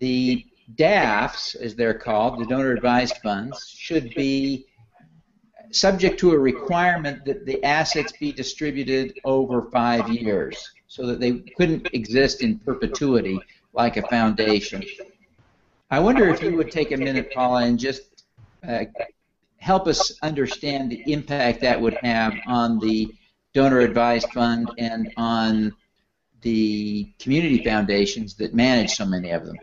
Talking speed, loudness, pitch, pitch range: 140 wpm, -22 LUFS, 125 Hz, 115-145 Hz